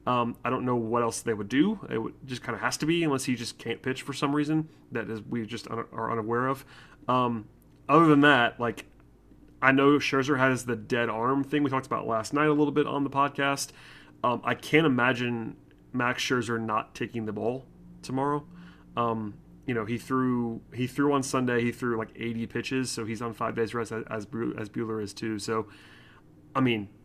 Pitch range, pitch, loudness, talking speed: 115-140 Hz, 120 Hz, -28 LUFS, 215 wpm